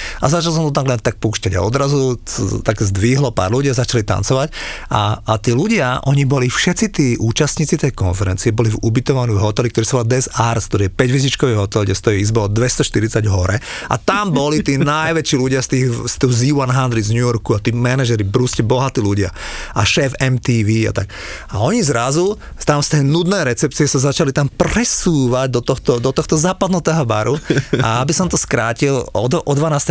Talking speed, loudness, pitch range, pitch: 200 wpm, -16 LUFS, 115-145 Hz, 130 Hz